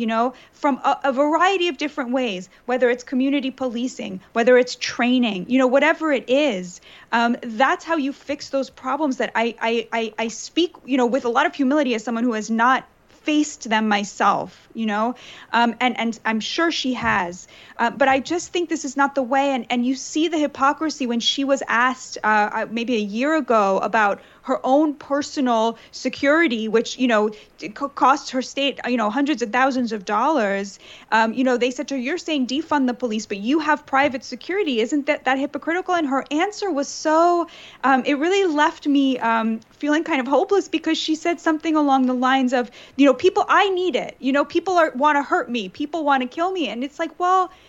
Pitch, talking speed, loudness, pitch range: 270 Hz, 210 wpm, -21 LUFS, 235-300 Hz